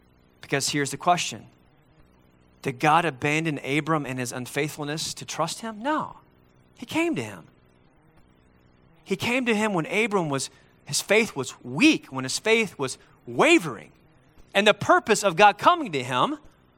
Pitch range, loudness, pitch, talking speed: 130-215 Hz, -24 LUFS, 155 Hz, 155 wpm